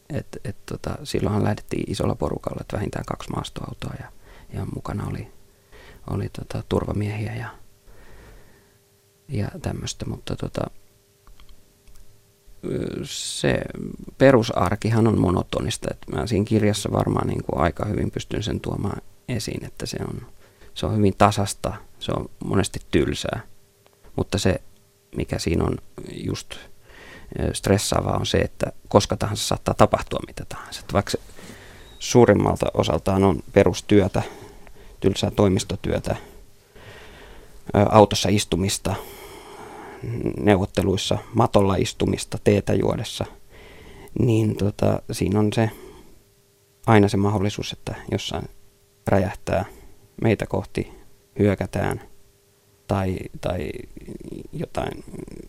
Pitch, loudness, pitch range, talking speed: 100 Hz, -23 LUFS, 100-105 Hz, 105 wpm